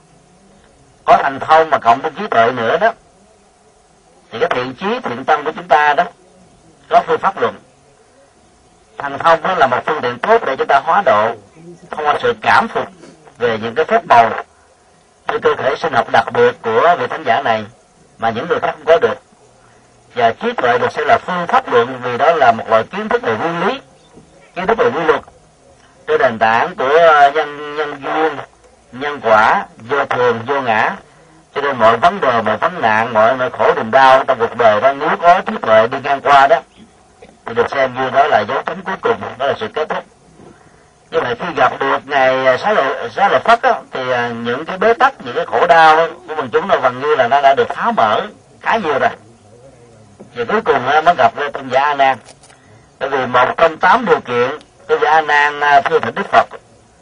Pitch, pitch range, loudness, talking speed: 160 Hz, 135-225 Hz, -14 LUFS, 215 wpm